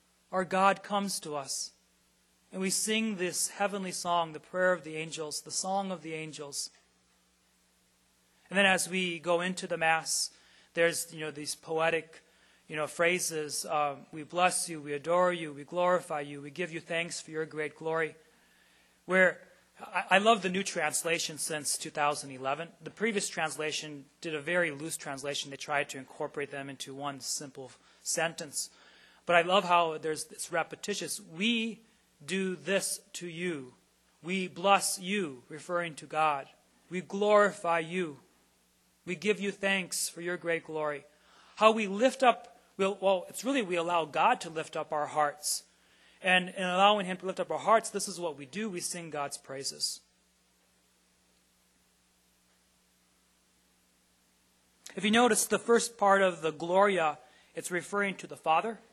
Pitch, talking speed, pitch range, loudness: 160 Hz, 160 wpm, 145-185 Hz, -31 LUFS